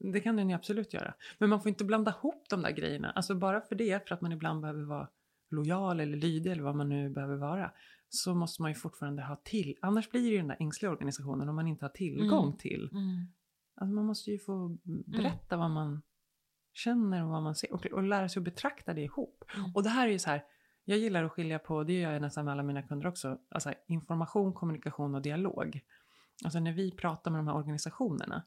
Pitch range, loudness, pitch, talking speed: 150-200 Hz, -35 LUFS, 175 Hz, 230 wpm